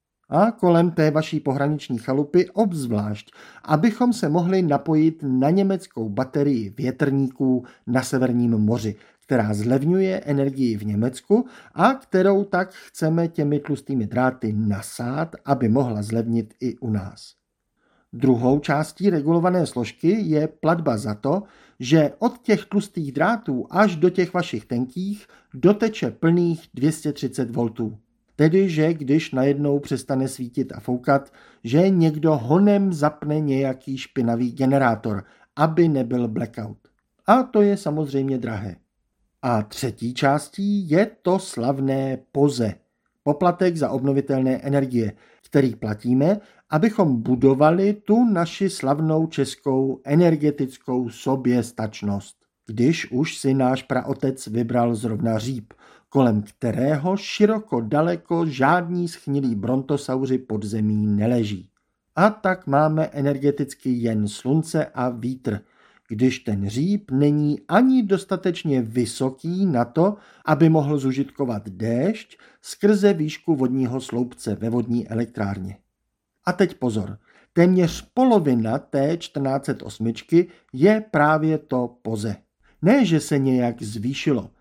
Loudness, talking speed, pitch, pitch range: -22 LUFS, 115 wpm, 140 Hz, 120-170 Hz